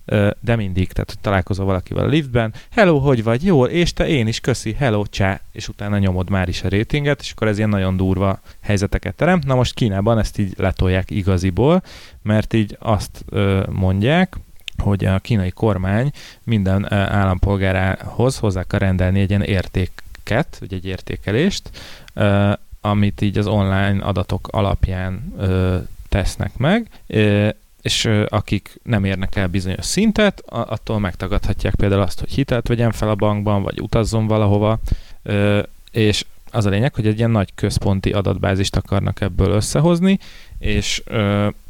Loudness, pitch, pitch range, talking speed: -19 LUFS, 105 Hz, 95-115 Hz, 145 wpm